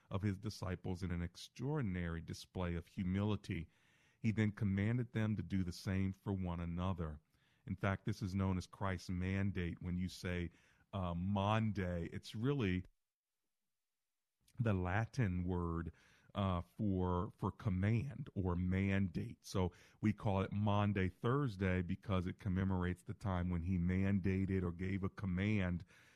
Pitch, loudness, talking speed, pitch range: 95 Hz, -40 LUFS, 140 wpm, 90-105 Hz